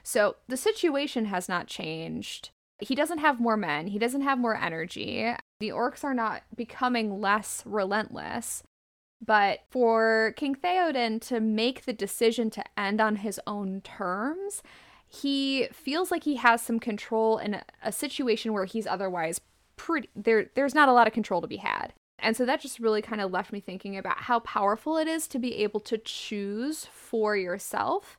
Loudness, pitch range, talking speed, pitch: -28 LUFS, 205-265 Hz, 180 wpm, 225 Hz